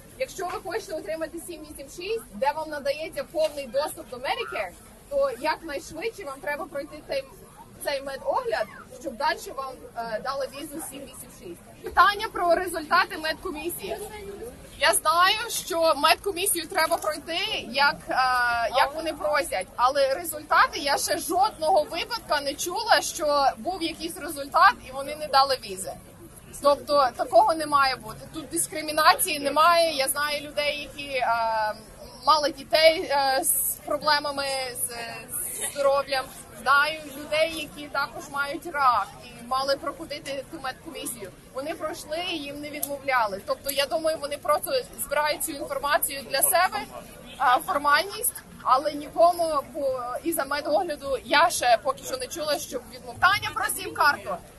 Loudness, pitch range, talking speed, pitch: -25 LUFS, 275-335 Hz, 135 wpm, 300 Hz